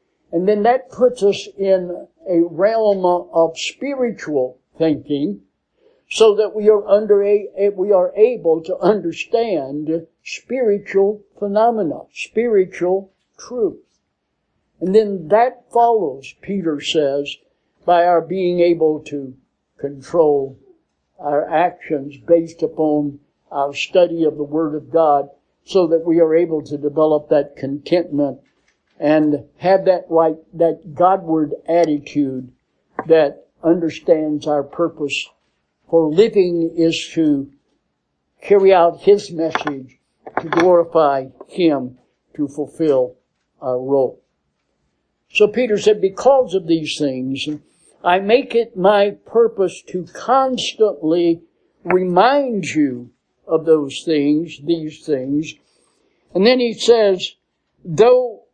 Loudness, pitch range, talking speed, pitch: -17 LUFS, 150-200 Hz, 115 wpm, 170 Hz